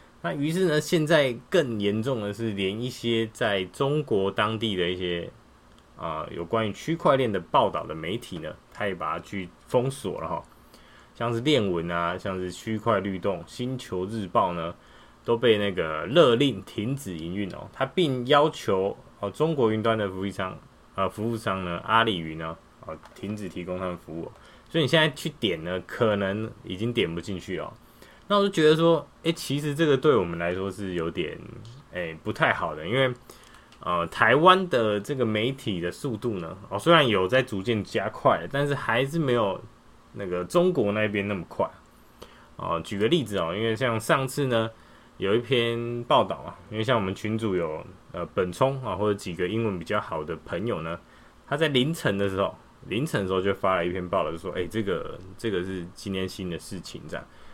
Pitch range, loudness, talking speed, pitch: 95-130 Hz, -26 LUFS, 280 characters per minute, 110 Hz